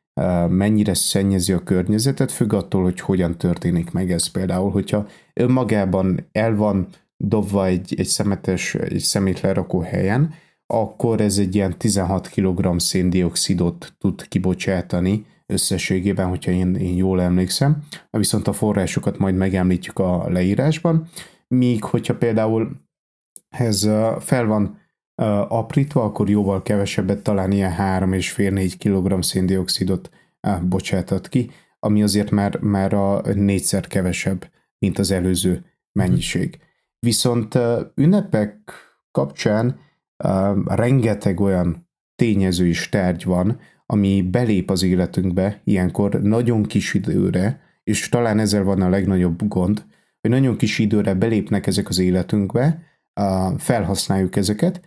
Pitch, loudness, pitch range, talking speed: 100 Hz, -20 LUFS, 95-110 Hz, 120 wpm